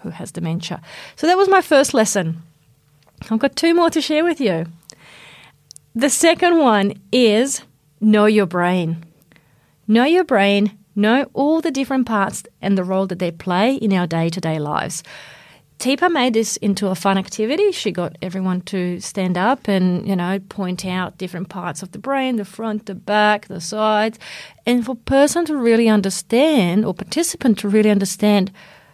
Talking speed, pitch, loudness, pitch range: 170 wpm, 205 Hz, -18 LUFS, 180-250 Hz